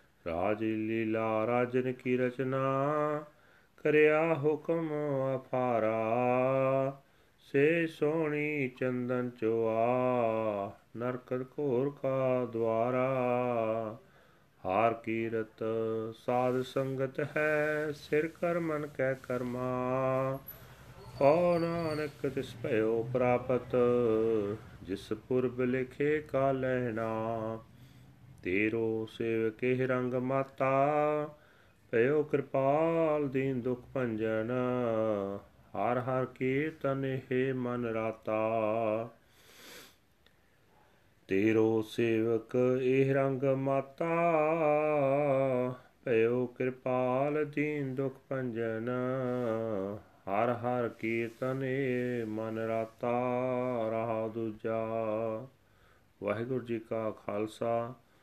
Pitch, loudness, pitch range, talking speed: 125 Hz, -32 LUFS, 115-135 Hz, 75 wpm